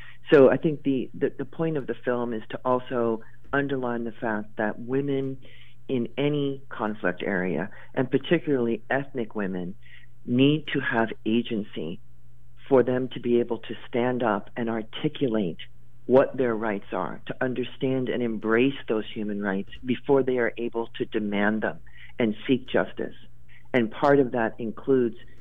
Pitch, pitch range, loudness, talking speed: 120 Hz, 110-130 Hz, -26 LUFS, 155 wpm